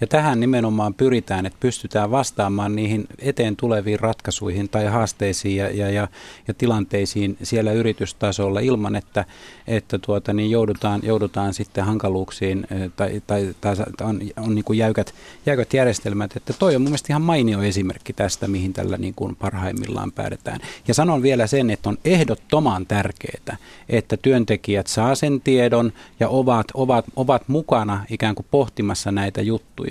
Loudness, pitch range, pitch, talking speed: -21 LUFS, 100-125 Hz, 110 Hz, 155 wpm